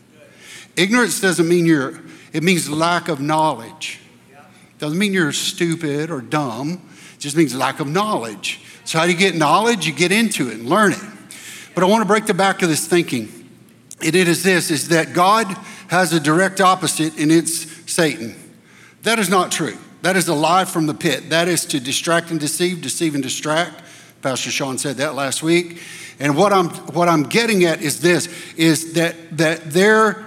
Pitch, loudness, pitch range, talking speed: 165 Hz, -17 LUFS, 155-180 Hz, 190 wpm